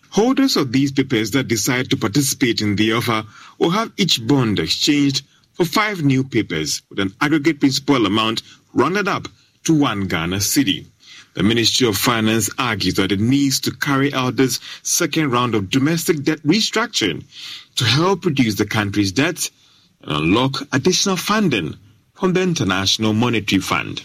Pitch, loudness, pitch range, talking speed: 130 Hz, -18 LUFS, 110-155 Hz, 160 wpm